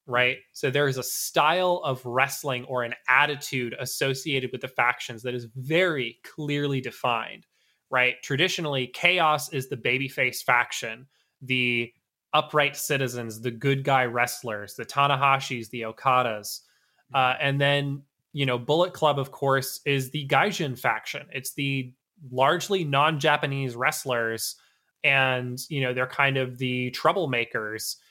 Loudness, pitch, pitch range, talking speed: -25 LUFS, 135 Hz, 125-145 Hz, 140 wpm